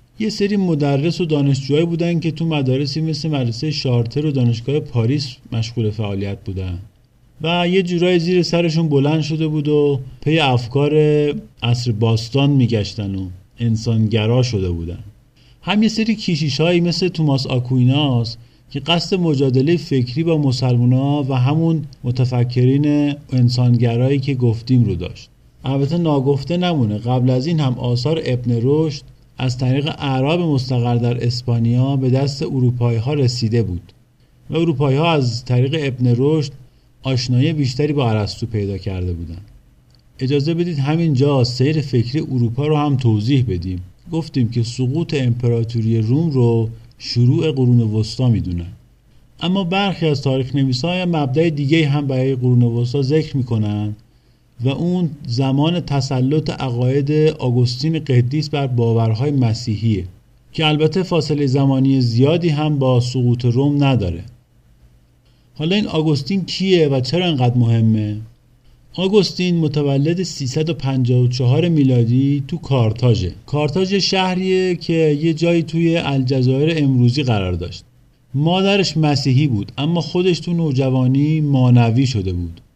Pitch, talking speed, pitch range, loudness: 135 Hz, 135 wpm, 120-155 Hz, -17 LUFS